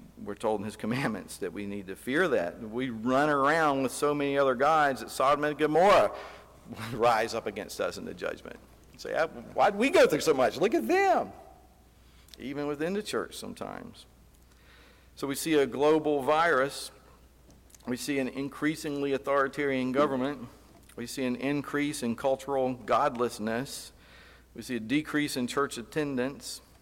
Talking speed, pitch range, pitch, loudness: 165 wpm, 120-145 Hz, 135 Hz, -28 LUFS